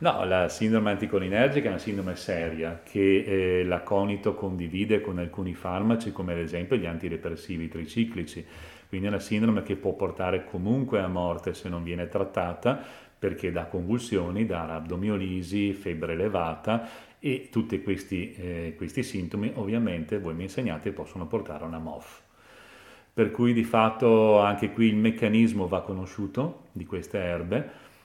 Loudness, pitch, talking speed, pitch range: -28 LUFS, 95 Hz, 150 wpm, 85-110 Hz